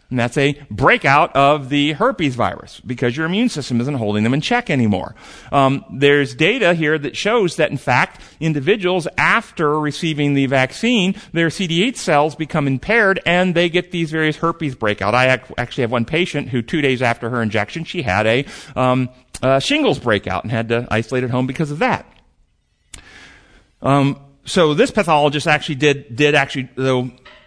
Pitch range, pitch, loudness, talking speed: 125-165 Hz, 145 Hz, -17 LUFS, 175 wpm